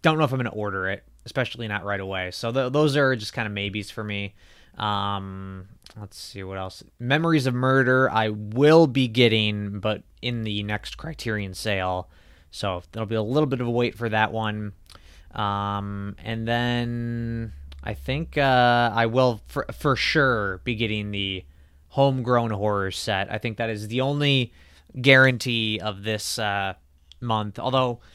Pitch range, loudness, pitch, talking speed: 100-125 Hz, -24 LUFS, 110 Hz, 175 wpm